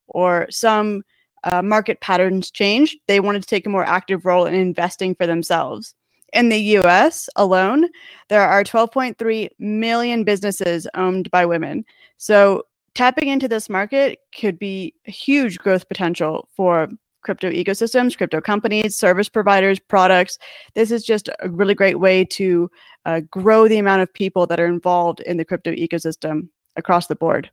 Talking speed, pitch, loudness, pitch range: 160 wpm, 195 Hz, -18 LUFS, 180-220 Hz